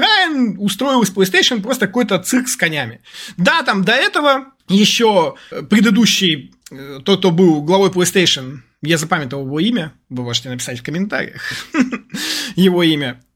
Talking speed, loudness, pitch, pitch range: 130 wpm, -15 LUFS, 190 Hz, 155-245 Hz